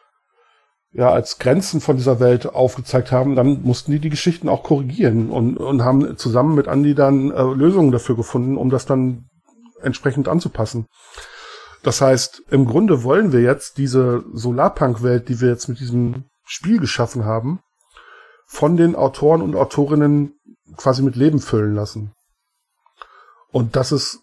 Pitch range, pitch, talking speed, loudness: 125-150 Hz, 135 Hz, 150 wpm, -17 LUFS